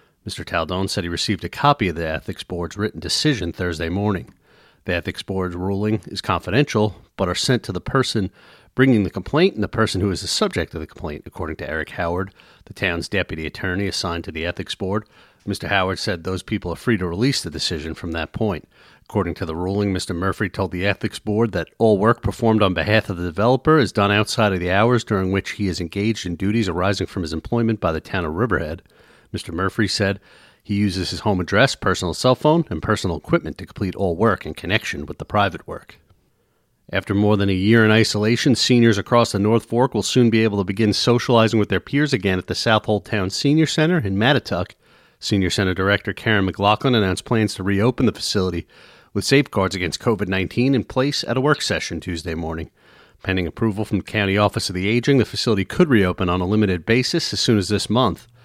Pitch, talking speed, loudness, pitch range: 100 Hz, 215 wpm, -20 LUFS, 95-115 Hz